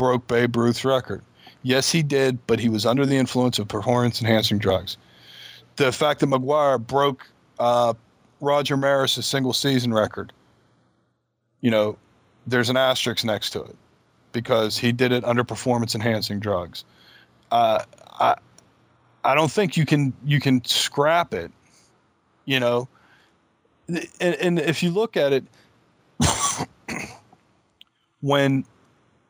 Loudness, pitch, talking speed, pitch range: -22 LUFS, 125 Hz, 125 wpm, 115-140 Hz